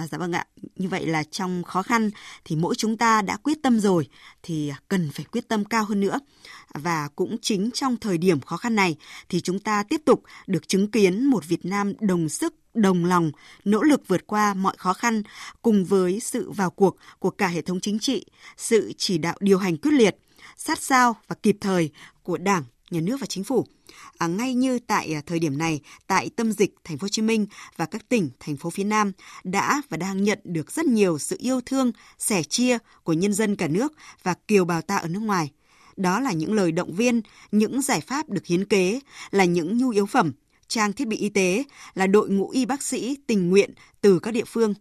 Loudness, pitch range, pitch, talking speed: -24 LUFS, 175-225 Hz, 200 Hz, 220 wpm